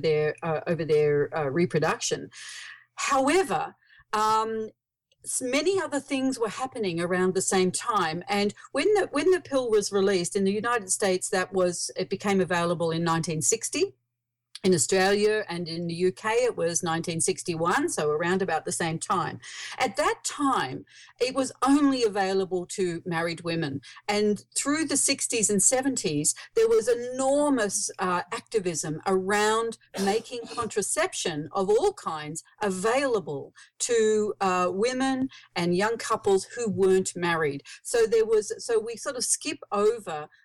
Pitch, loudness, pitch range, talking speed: 205 Hz, -26 LUFS, 175-265 Hz, 145 wpm